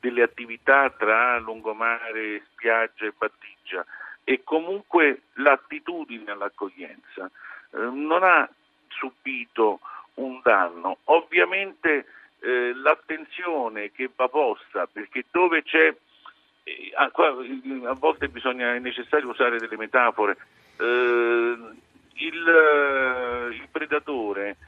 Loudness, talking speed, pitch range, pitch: -23 LUFS, 95 wpm, 120-155 Hz, 130 Hz